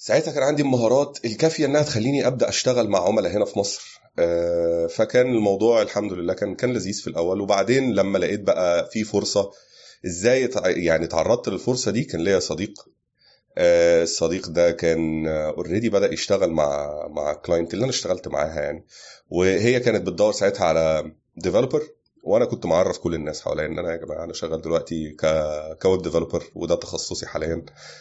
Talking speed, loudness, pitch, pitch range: 160 wpm, -22 LUFS, 95 Hz, 85-120 Hz